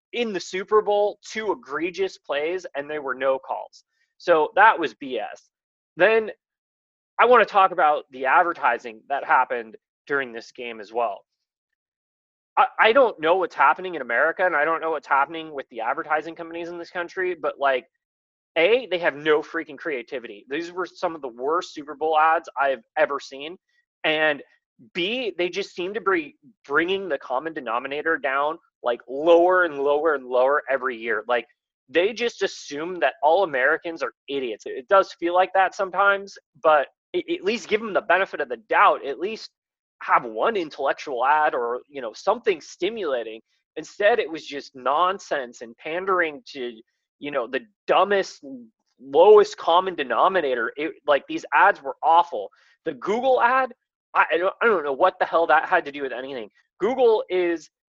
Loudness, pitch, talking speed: -22 LUFS, 180 Hz, 175 wpm